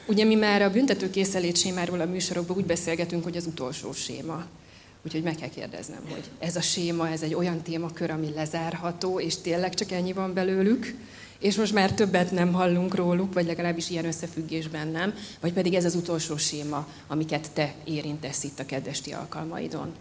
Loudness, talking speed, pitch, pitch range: -27 LUFS, 175 wpm, 170 Hz, 160-185 Hz